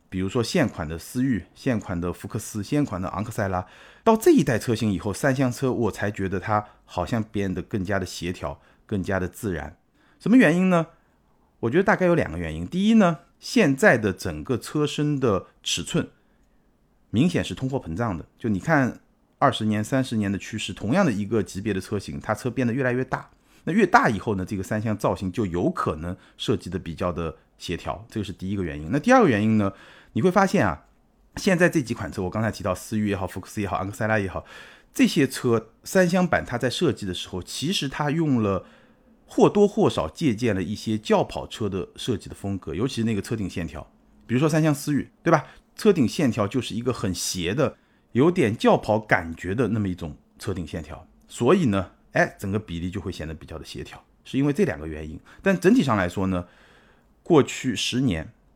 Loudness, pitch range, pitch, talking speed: -24 LUFS, 90-135 Hz, 105 Hz, 310 characters per minute